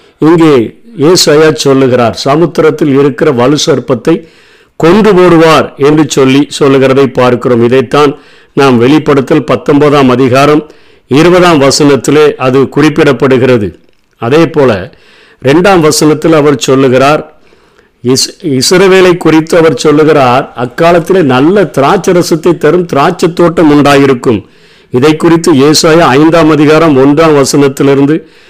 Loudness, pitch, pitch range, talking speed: -6 LUFS, 150 Hz, 135-165 Hz, 95 wpm